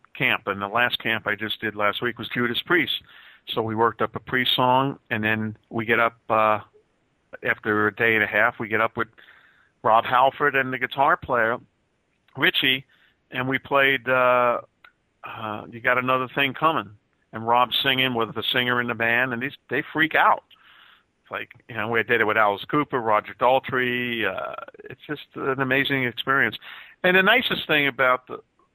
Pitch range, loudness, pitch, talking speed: 110-135 Hz, -22 LUFS, 120 Hz, 190 wpm